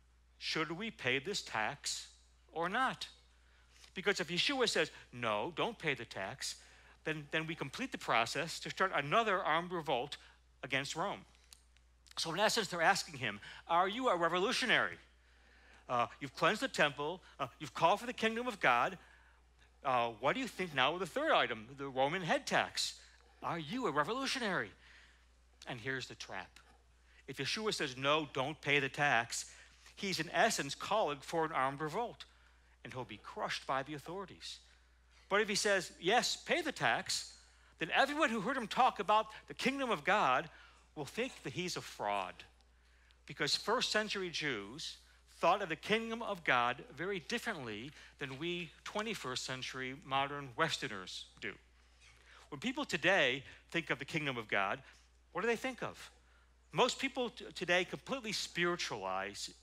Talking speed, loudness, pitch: 160 wpm, -36 LUFS, 140 Hz